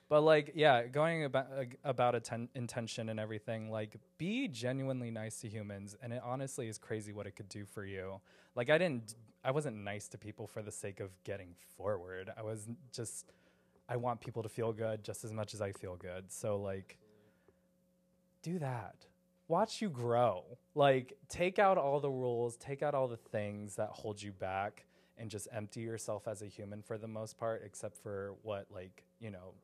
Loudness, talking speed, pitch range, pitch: -38 LUFS, 200 wpm, 105-135 Hz, 115 Hz